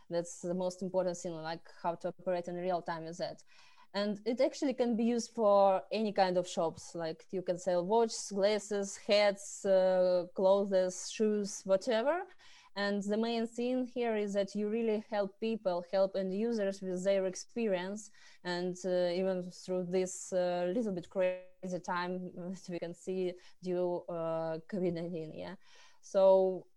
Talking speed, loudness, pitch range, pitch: 160 wpm, -34 LUFS, 180-210 Hz, 190 Hz